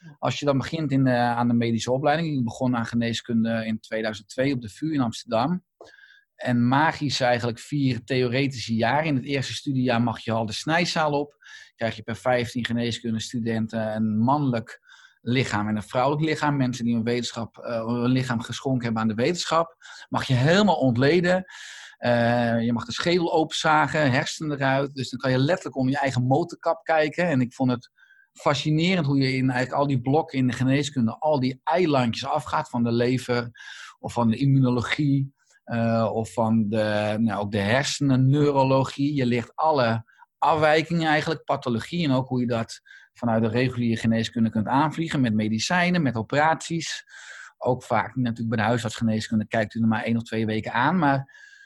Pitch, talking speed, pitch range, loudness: 125 Hz, 180 wpm, 115-145 Hz, -24 LUFS